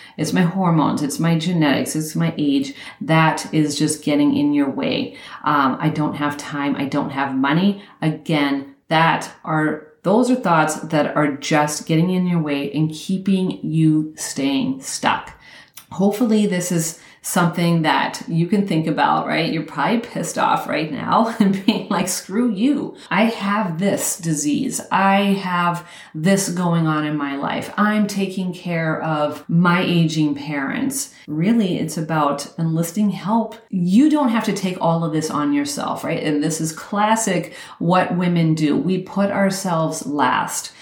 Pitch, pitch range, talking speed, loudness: 175 Hz, 155-205 Hz, 160 wpm, -19 LUFS